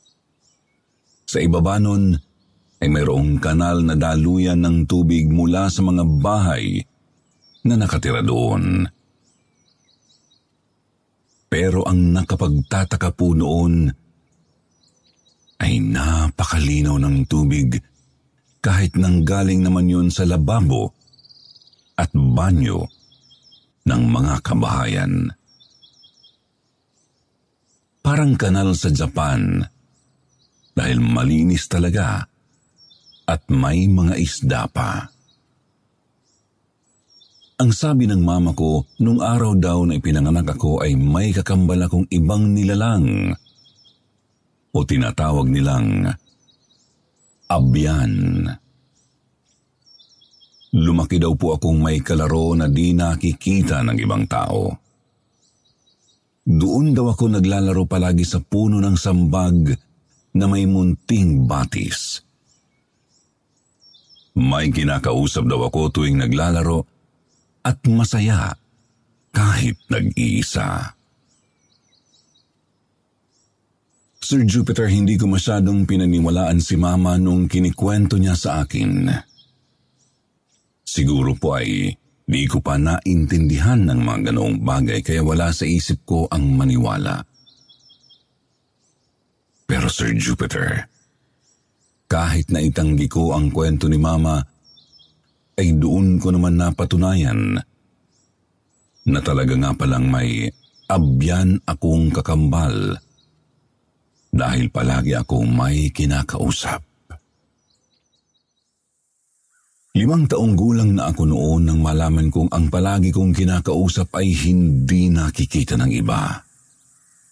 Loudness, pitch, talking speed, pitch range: -18 LUFS, 90 Hz, 95 wpm, 80-105 Hz